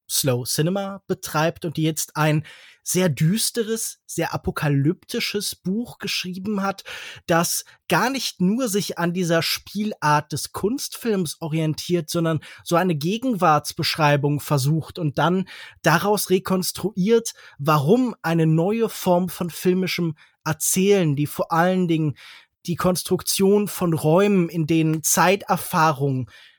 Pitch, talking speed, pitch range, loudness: 175 Hz, 115 wpm, 155-195 Hz, -22 LUFS